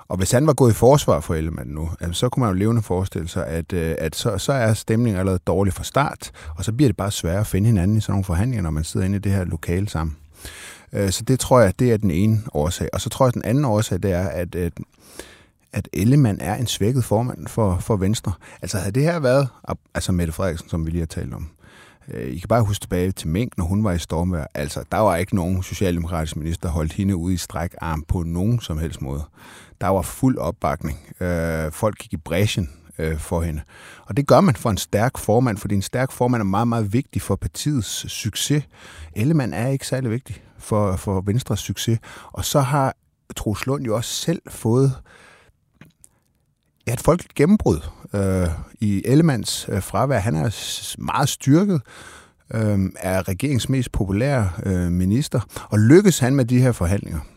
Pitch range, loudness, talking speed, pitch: 90-120 Hz, -21 LUFS, 205 wpm, 100 Hz